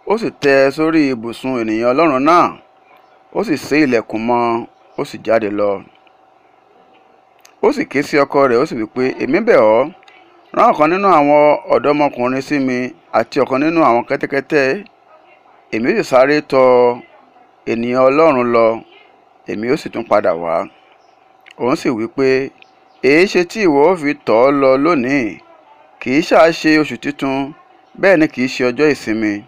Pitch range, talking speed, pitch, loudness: 120-150 Hz, 165 wpm, 135 Hz, -14 LUFS